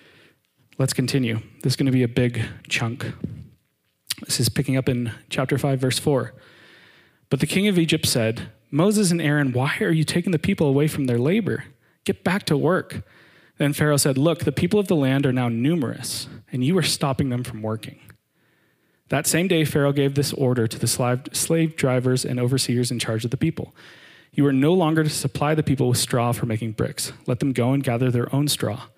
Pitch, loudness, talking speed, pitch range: 135 Hz, -22 LUFS, 205 wpm, 125-155 Hz